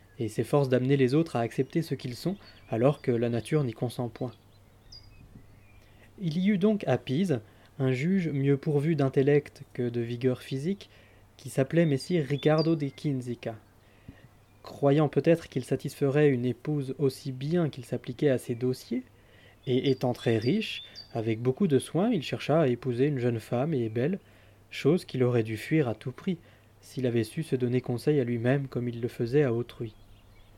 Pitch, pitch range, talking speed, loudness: 125 Hz, 115-145 Hz, 175 wpm, -28 LUFS